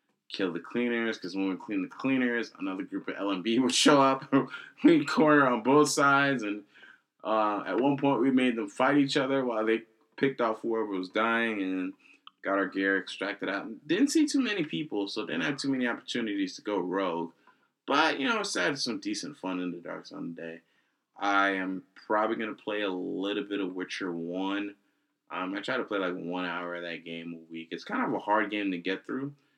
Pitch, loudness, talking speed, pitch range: 115 Hz, -29 LUFS, 215 wpm, 95-140 Hz